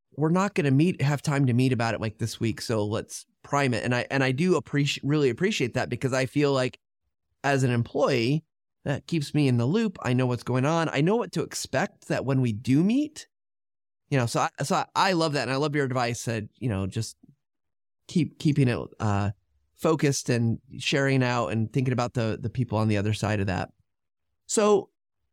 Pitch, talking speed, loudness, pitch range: 130 Hz, 225 wpm, -26 LUFS, 110-145 Hz